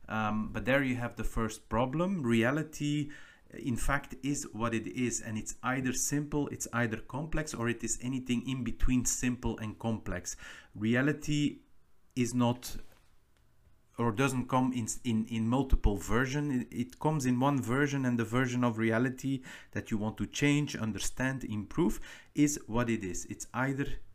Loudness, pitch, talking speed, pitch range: -33 LUFS, 120 Hz, 160 wpm, 110-135 Hz